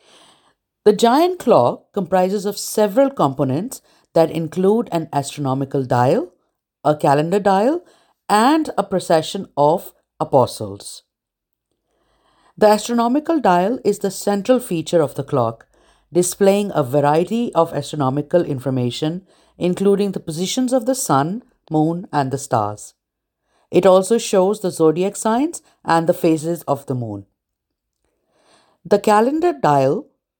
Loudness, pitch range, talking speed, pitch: -18 LUFS, 150-210 Hz, 120 wpm, 180 Hz